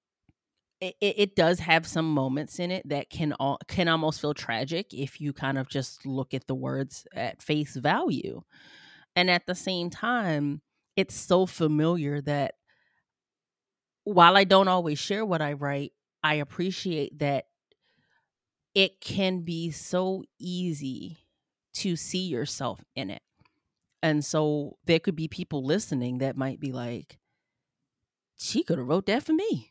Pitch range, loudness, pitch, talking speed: 140-180 Hz, -27 LUFS, 160 Hz, 150 wpm